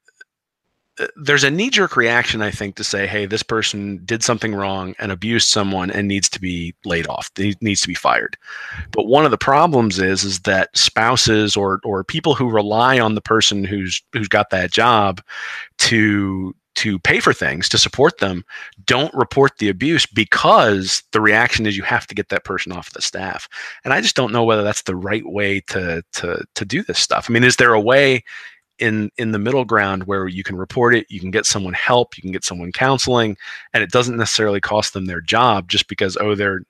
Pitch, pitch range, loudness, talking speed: 105 Hz, 95-120 Hz, -17 LUFS, 210 wpm